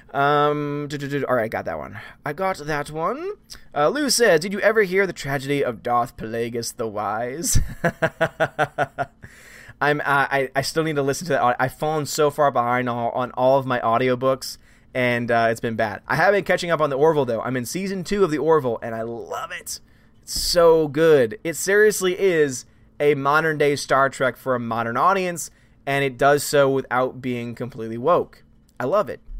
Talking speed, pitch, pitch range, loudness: 210 wpm, 140 Hz, 120-160 Hz, -21 LUFS